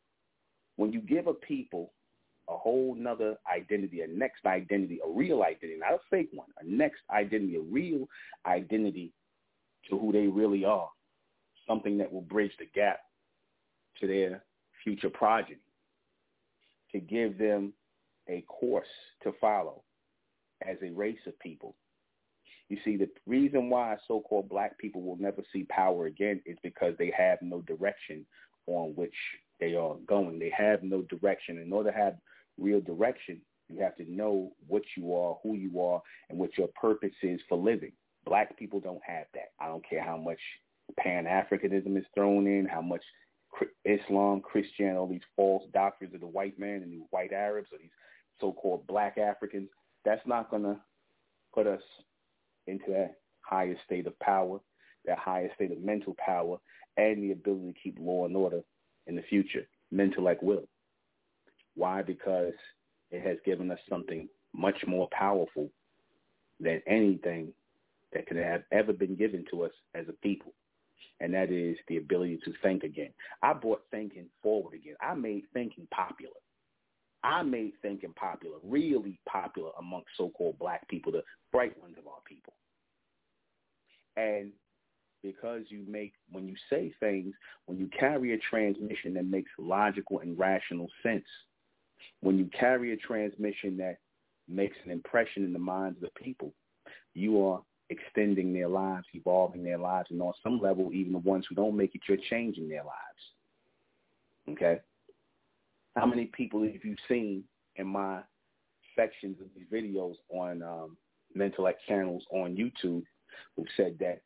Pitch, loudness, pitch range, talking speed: 100 Hz, -32 LUFS, 90-105 Hz, 160 wpm